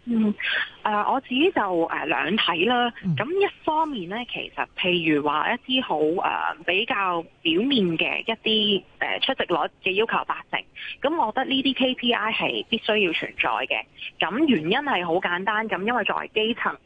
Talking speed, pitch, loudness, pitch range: 255 characters per minute, 225 Hz, -23 LUFS, 180-260 Hz